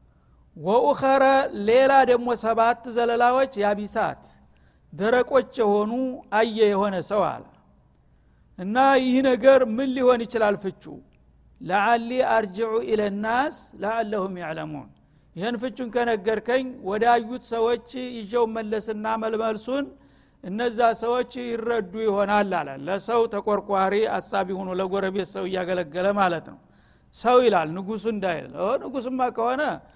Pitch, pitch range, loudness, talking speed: 225 Hz, 195-245 Hz, -23 LUFS, 105 wpm